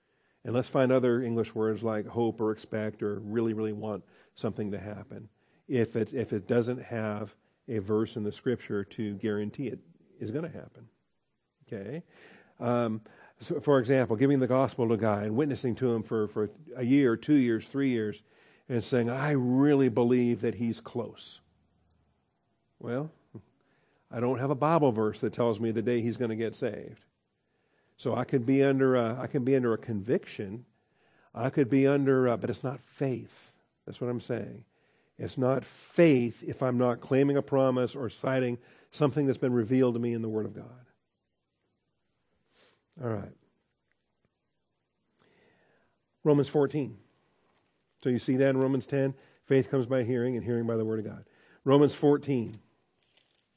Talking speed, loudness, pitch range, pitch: 170 wpm, -29 LUFS, 110-135 Hz, 120 Hz